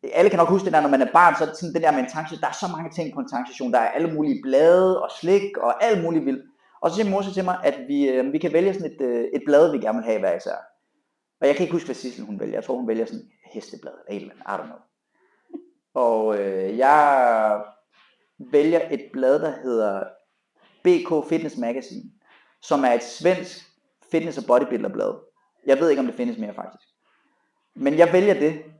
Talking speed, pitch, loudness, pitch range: 220 wpm, 170 Hz, -21 LUFS, 140-225 Hz